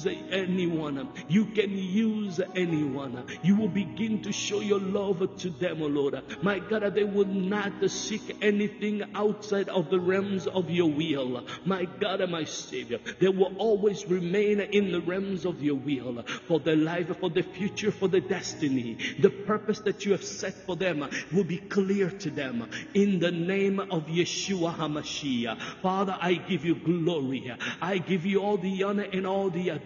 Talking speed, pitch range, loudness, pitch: 175 wpm, 170-200 Hz, -28 LUFS, 190 Hz